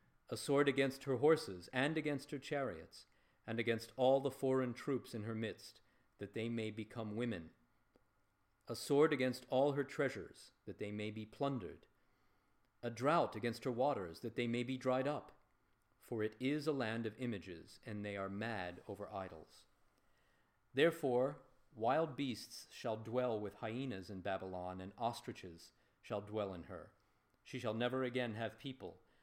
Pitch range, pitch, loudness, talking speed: 105-130 Hz, 120 Hz, -40 LUFS, 160 wpm